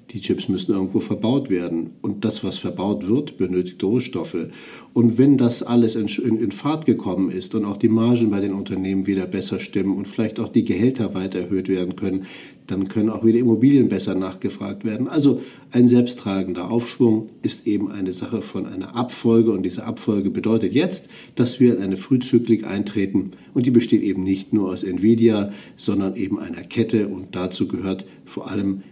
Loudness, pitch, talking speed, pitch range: -21 LUFS, 105 Hz, 180 wpm, 95-120 Hz